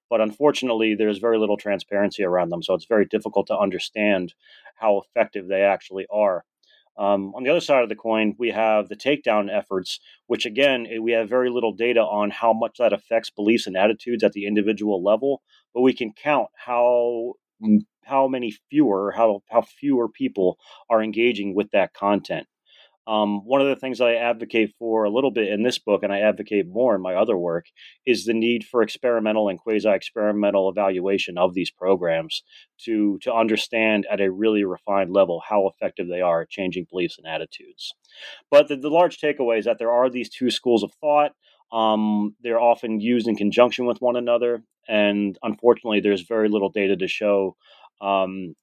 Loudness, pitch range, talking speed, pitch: -22 LUFS, 100-120 Hz, 185 wpm, 110 Hz